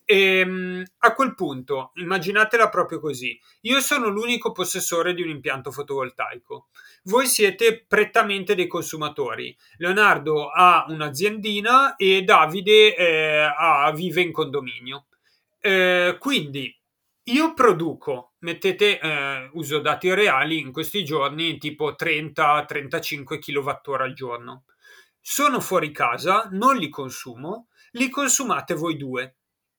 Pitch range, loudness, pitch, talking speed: 150-215 Hz, -21 LUFS, 175 Hz, 115 wpm